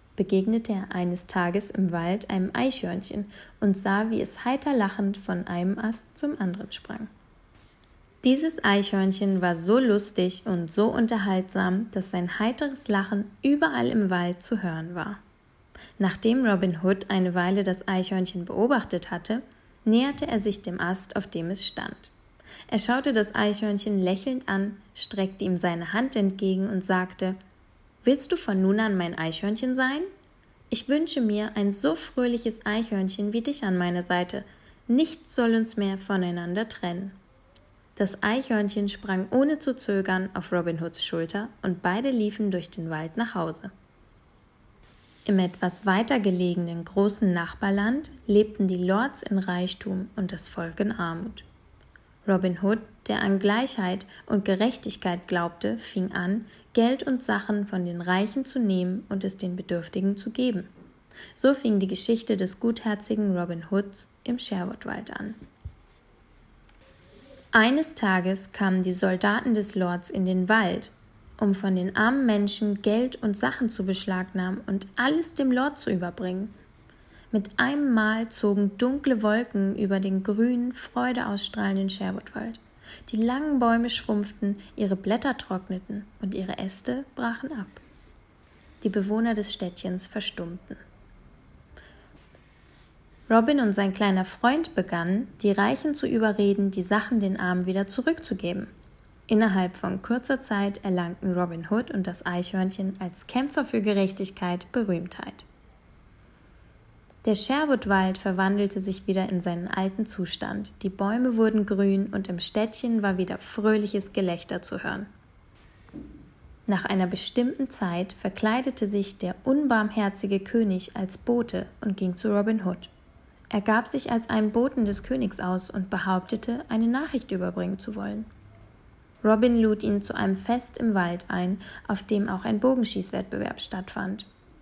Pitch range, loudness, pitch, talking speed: 185-225 Hz, -26 LUFS, 200 Hz, 140 wpm